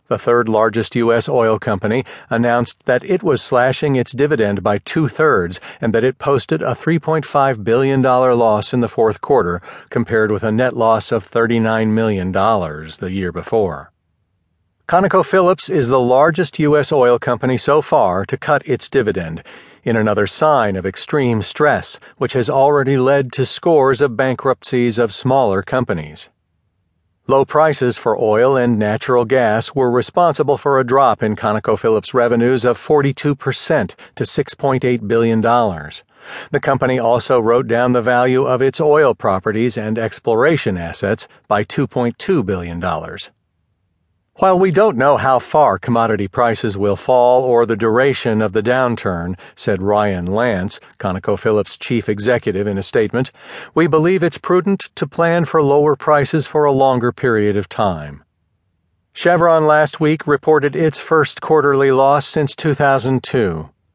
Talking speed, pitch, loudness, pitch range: 145 wpm, 125 Hz, -15 LUFS, 110-145 Hz